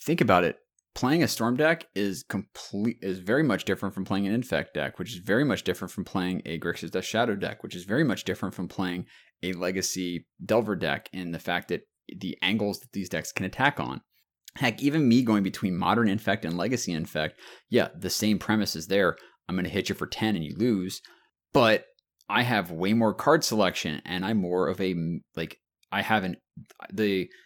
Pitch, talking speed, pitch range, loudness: 95 Hz, 205 wpm, 90-105 Hz, -27 LUFS